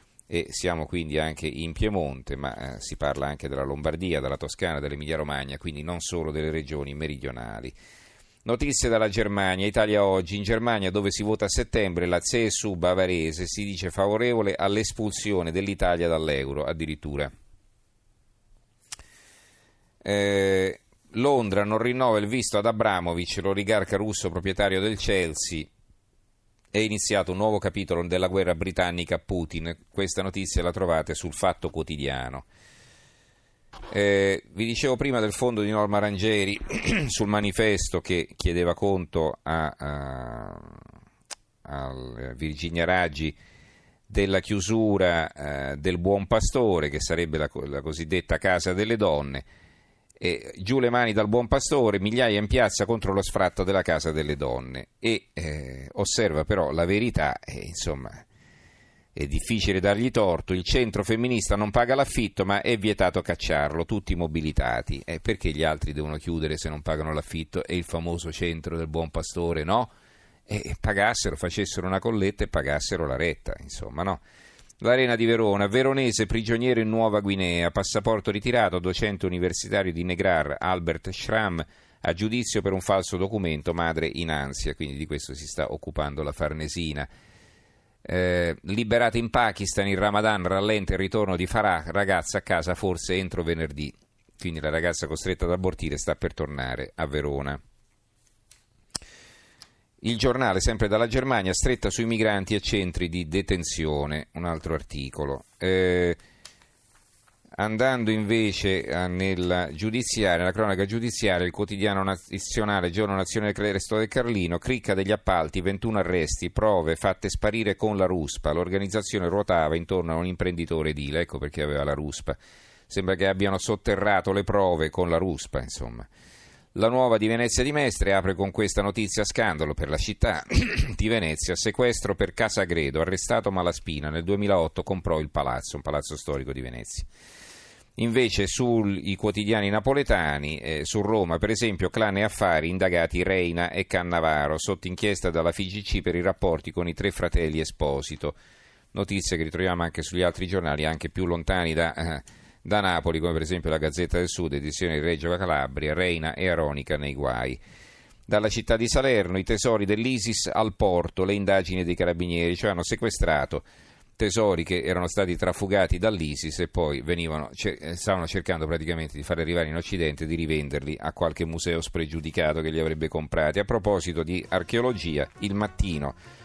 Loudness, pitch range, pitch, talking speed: -26 LUFS, 80-105 Hz, 90 Hz, 150 wpm